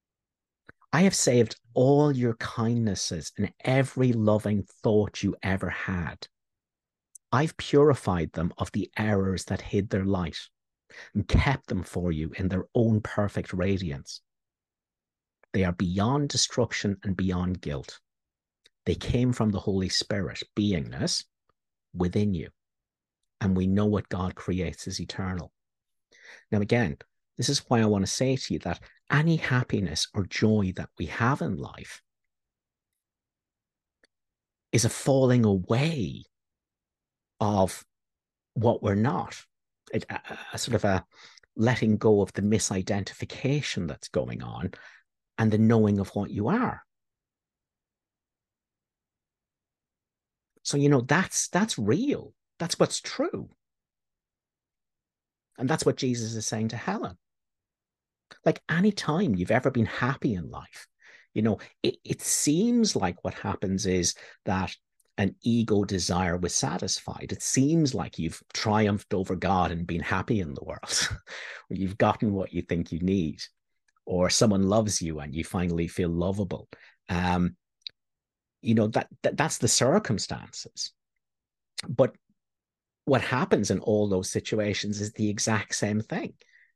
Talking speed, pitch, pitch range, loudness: 135 wpm, 105 Hz, 95-120 Hz, -27 LUFS